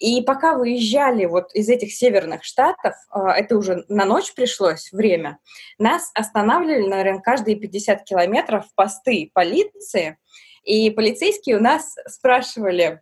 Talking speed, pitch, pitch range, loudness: 125 wpm, 220 Hz, 195-255 Hz, -19 LUFS